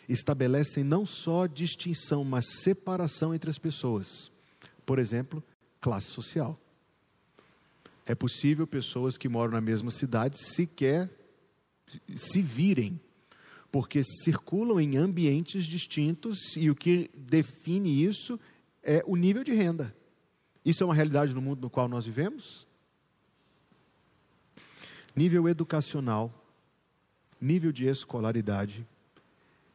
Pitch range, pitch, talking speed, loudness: 130-170 Hz, 150 Hz, 110 wpm, -30 LUFS